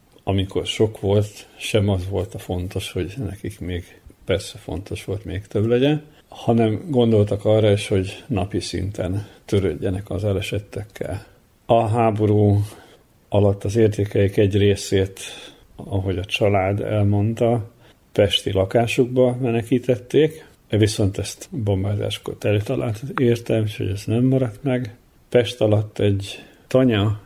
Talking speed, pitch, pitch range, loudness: 125 wpm, 105 Hz, 100-115 Hz, -21 LUFS